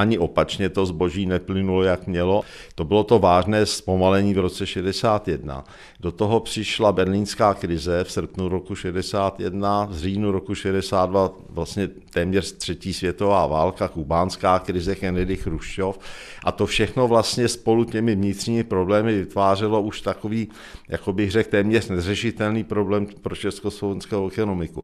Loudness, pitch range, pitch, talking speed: -22 LUFS, 95-105 Hz, 100 Hz, 140 wpm